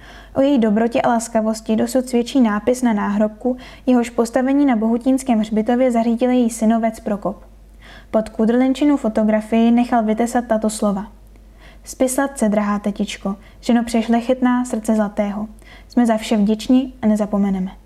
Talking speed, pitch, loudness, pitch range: 140 wpm, 230 Hz, -18 LUFS, 215-250 Hz